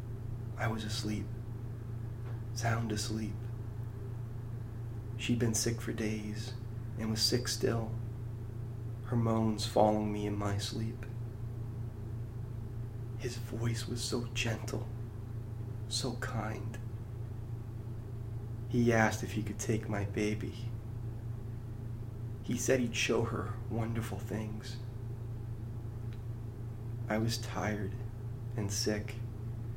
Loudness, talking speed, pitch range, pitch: -36 LUFS, 95 wpm, 110-115 Hz, 115 Hz